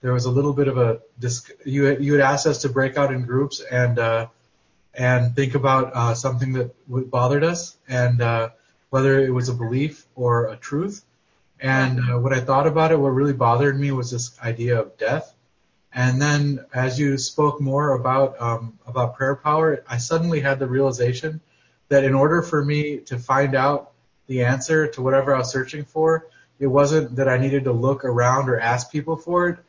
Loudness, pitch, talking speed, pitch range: -21 LUFS, 135 Hz, 195 wpm, 125-145 Hz